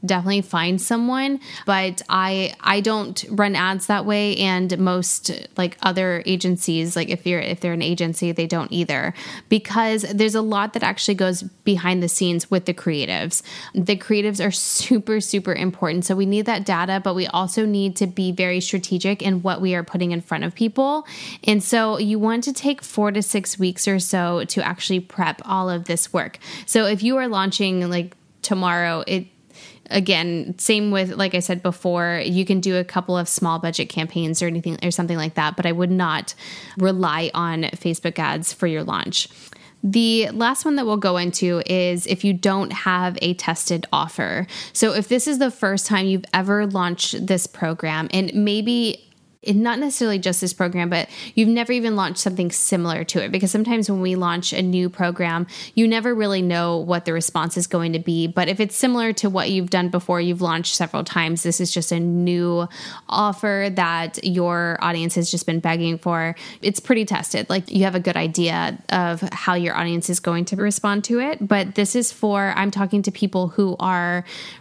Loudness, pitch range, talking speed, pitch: -21 LUFS, 175-205 Hz, 195 wpm, 185 Hz